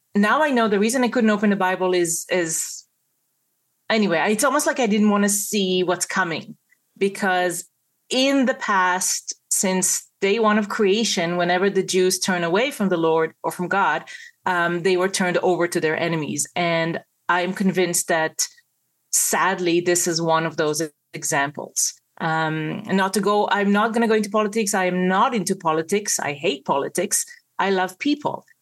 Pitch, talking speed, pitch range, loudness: 185 Hz, 175 wpm, 175-210 Hz, -21 LUFS